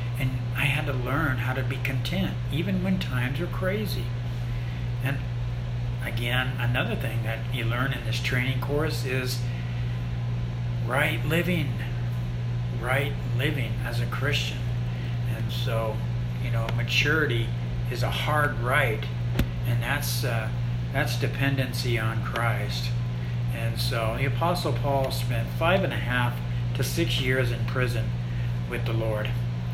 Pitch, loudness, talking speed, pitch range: 120 Hz, -27 LUFS, 135 wpm, 115-125 Hz